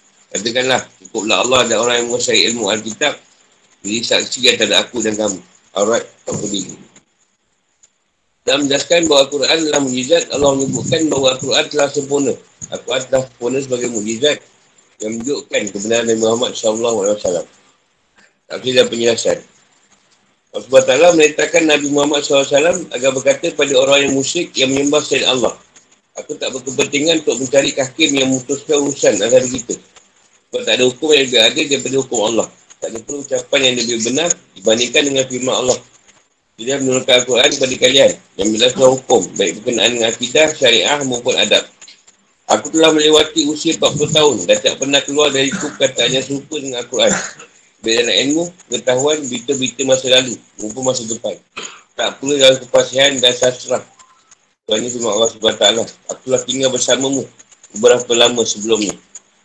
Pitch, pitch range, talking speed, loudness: 140 Hz, 125-155 Hz, 155 wpm, -14 LUFS